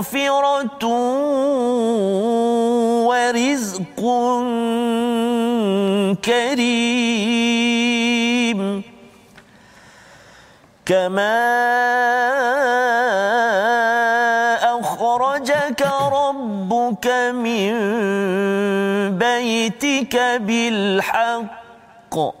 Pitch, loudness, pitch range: 235 Hz, -18 LUFS, 225-245 Hz